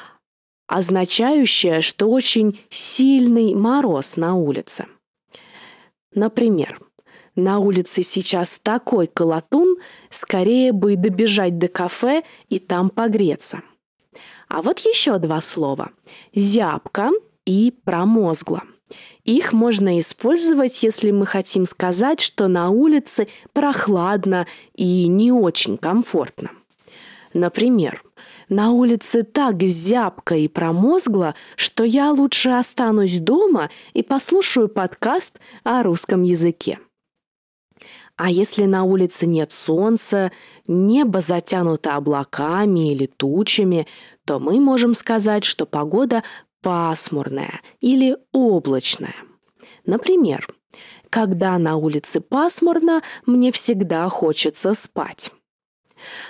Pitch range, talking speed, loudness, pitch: 180-245 Hz, 95 wpm, -18 LUFS, 205 Hz